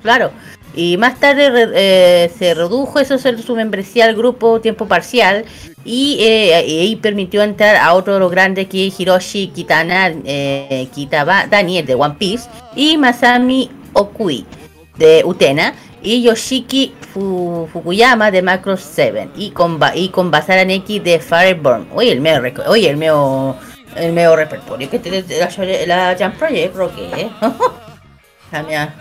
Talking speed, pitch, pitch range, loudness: 145 wpm, 190 Hz, 170-230 Hz, -13 LUFS